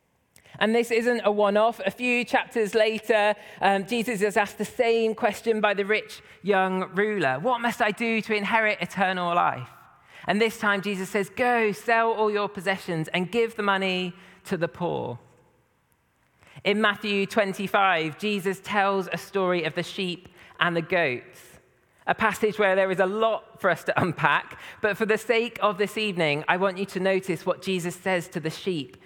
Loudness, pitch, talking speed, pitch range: -25 LUFS, 200 Hz, 185 wpm, 185-220 Hz